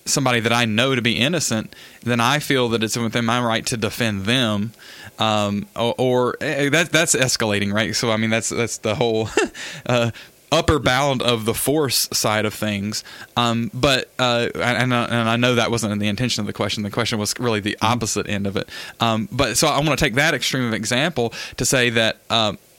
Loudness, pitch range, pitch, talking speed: -20 LUFS, 110-125 Hz, 115 Hz, 215 wpm